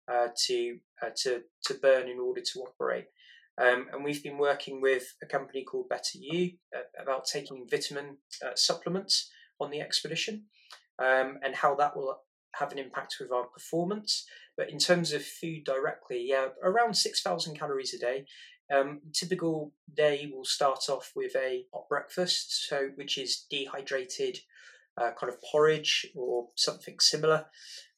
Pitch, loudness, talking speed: 155 Hz, -30 LUFS, 160 wpm